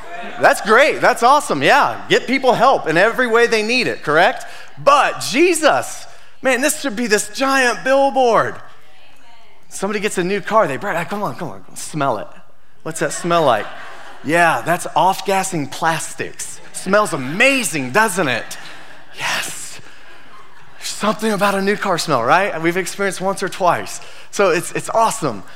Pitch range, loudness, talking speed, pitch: 185-235 Hz, -16 LUFS, 160 wpm, 210 Hz